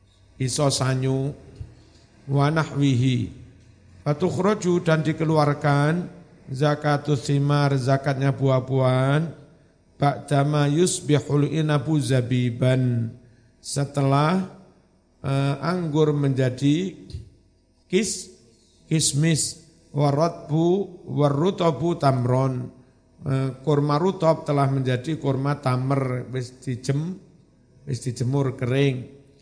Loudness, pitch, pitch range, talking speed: -23 LUFS, 140 Hz, 130-155 Hz, 65 wpm